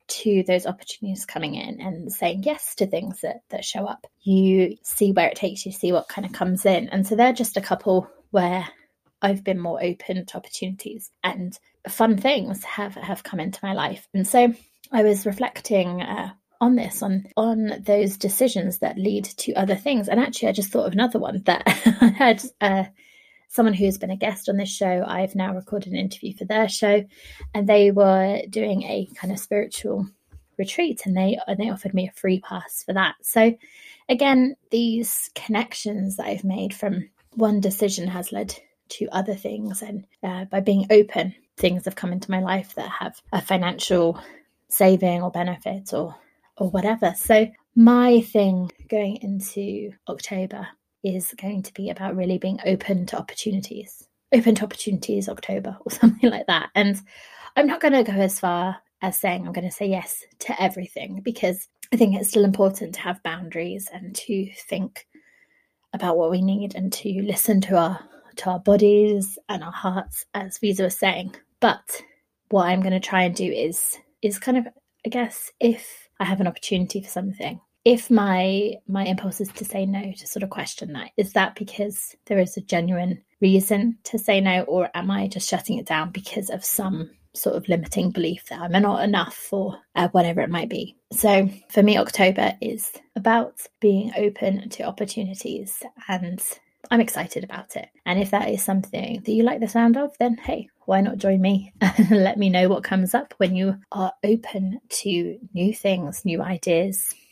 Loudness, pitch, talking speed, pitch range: -22 LUFS, 200 Hz, 190 wpm, 190-220 Hz